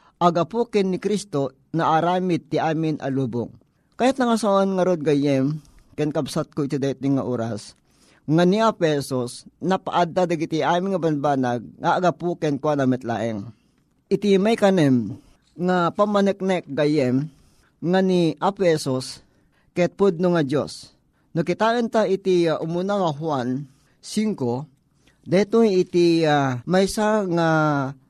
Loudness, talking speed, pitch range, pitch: -22 LUFS, 130 wpm, 140-185 Hz, 160 Hz